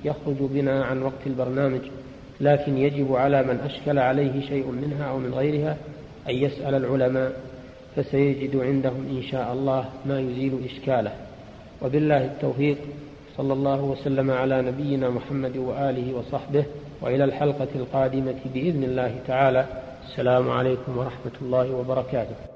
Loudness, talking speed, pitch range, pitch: -25 LUFS, 130 wpm, 130-140 Hz, 135 Hz